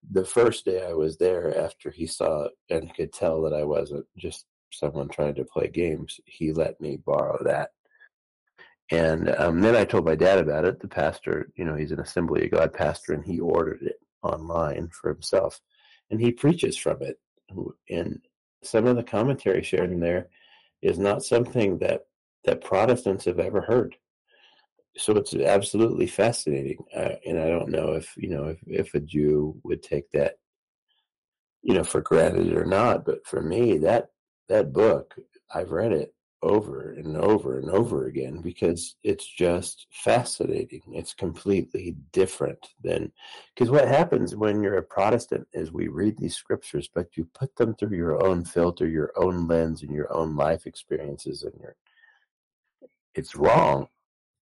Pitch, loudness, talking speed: 120 Hz, -25 LUFS, 170 wpm